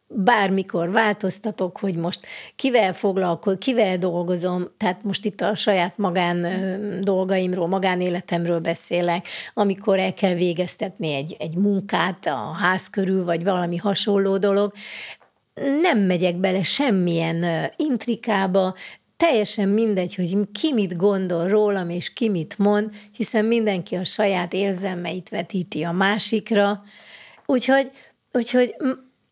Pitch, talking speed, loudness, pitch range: 195 Hz, 115 wpm, -22 LUFS, 180-210 Hz